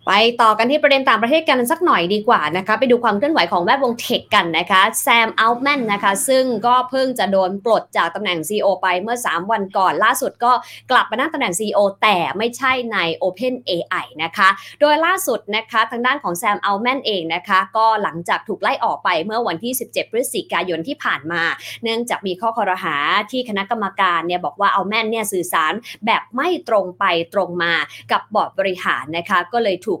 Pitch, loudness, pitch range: 220 Hz, -18 LUFS, 190-250 Hz